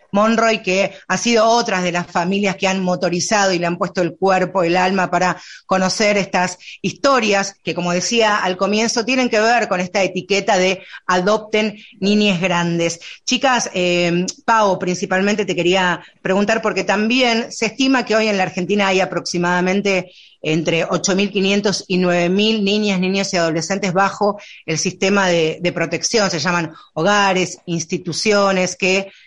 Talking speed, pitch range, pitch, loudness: 155 wpm, 180-205 Hz, 190 Hz, -17 LUFS